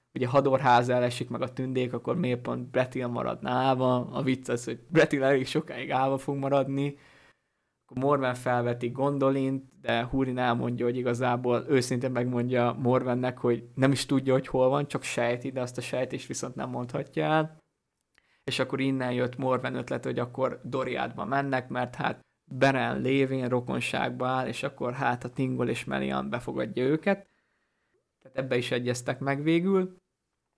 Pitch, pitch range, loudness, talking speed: 130 Hz, 125-135 Hz, -28 LUFS, 160 wpm